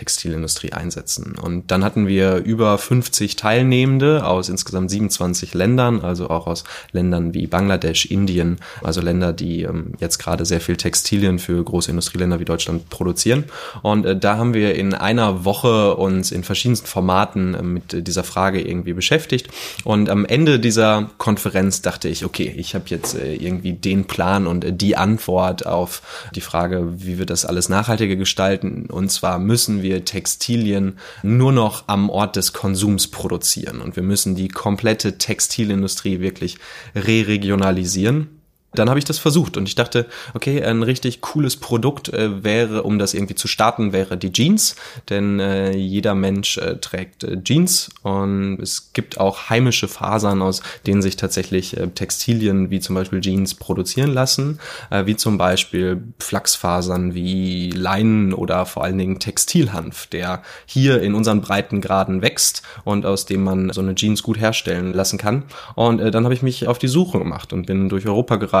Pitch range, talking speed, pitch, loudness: 95-110 Hz, 165 wpm, 100 Hz, -19 LUFS